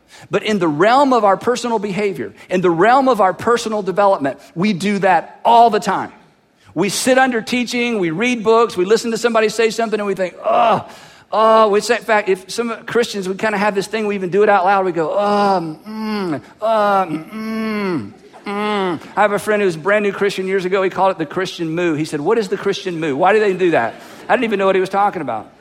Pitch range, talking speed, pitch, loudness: 190-220 Hz, 240 wpm, 205 Hz, -16 LUFS